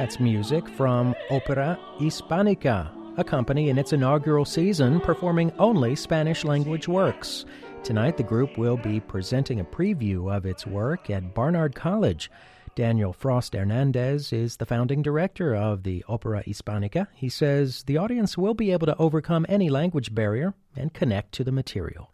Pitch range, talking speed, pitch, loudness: 110-160 Hz, 155 wpm, 135 Hz, -25 LUFS